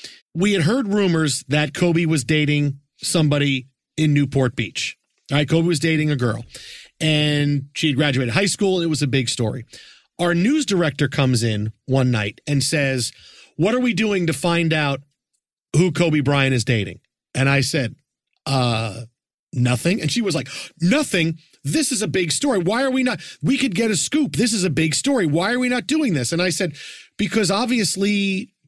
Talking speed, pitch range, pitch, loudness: 190 wpm, 135-190 Hz, 155 Hz, -20 LUFS